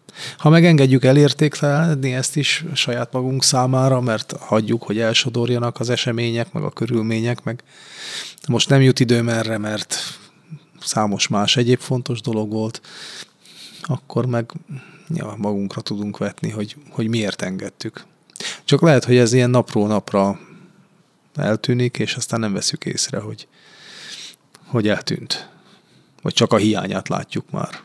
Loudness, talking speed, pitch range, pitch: -19 LUFS, 135 wpm, 110-140 Hz, 120 Hz